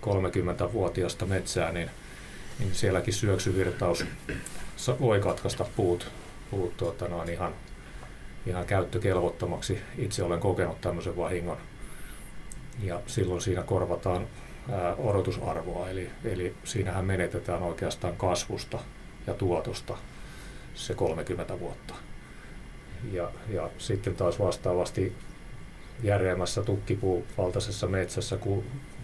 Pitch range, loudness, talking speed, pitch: 90-105 Hz, -31 LUFS, 100 wpm, 95 Hz